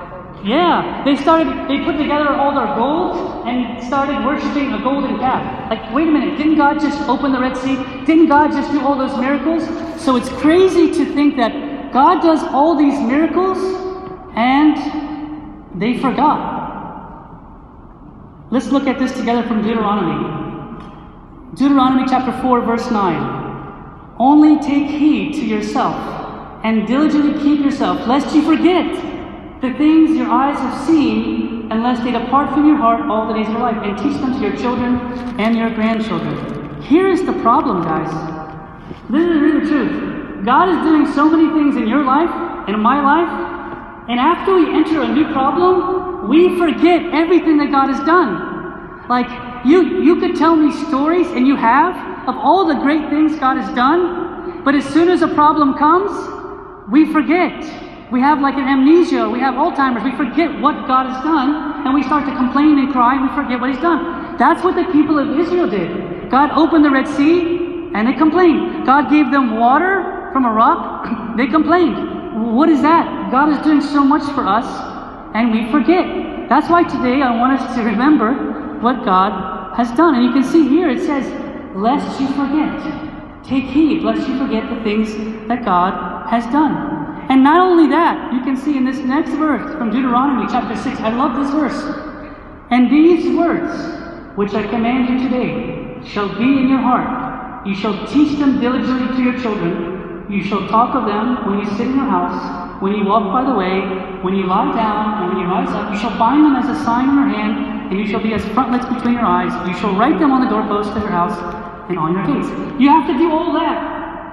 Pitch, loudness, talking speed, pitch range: 280 Hz, -15 LUFS, 190 wpm, 245-315 Hz